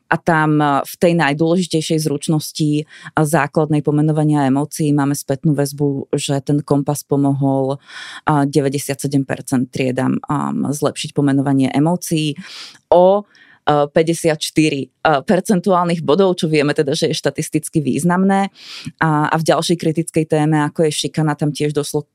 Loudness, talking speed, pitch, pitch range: -17 LUFS, 120 wpm, 150 Hz, 140-160 Hz